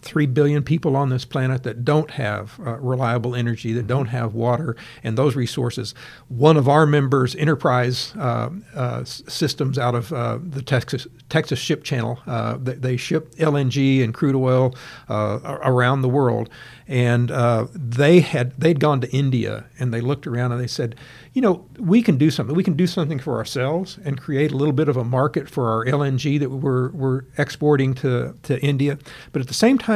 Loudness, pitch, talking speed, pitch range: -21 LUFS, 135 Hz, 195 wpm, 125-150 Hz